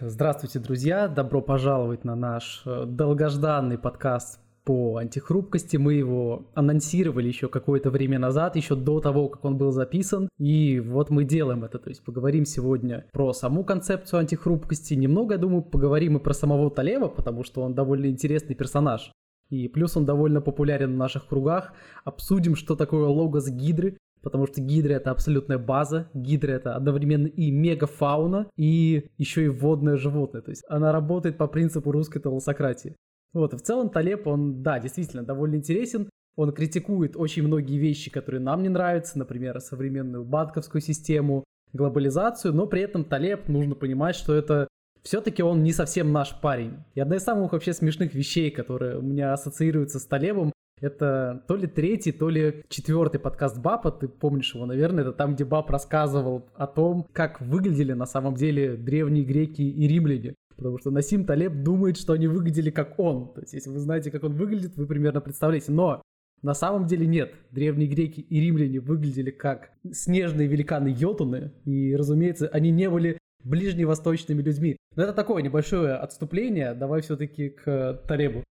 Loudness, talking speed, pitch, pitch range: -25 LUFS, 165 wpm, 150 Hz, 135-160 Hz